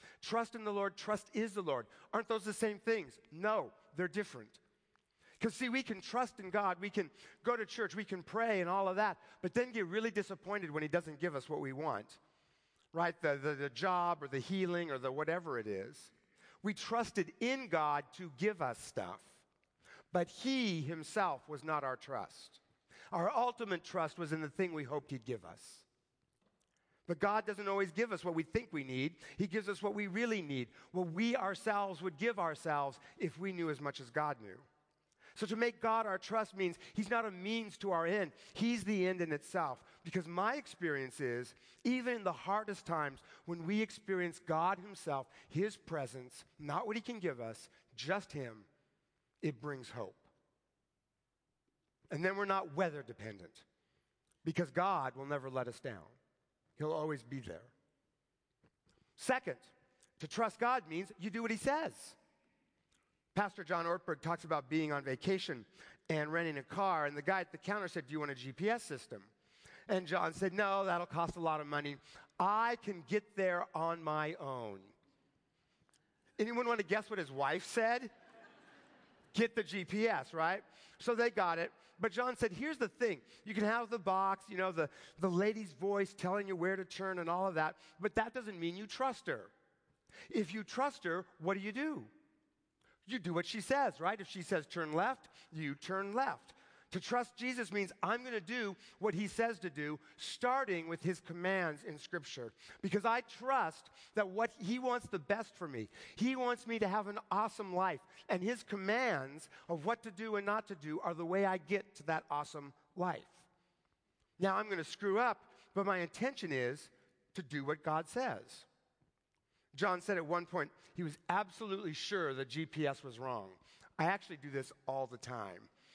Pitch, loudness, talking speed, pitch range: 185 Hz, -39 LUFS, 190 wpm, 155-215 Hz